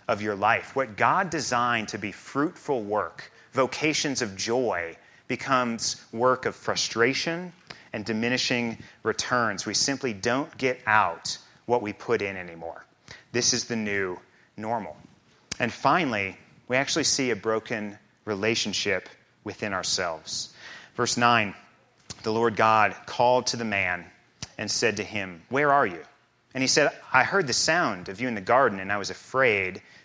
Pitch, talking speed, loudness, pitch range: 115 Hz, 155 wpm, -26 LUFS, 105-125 Hz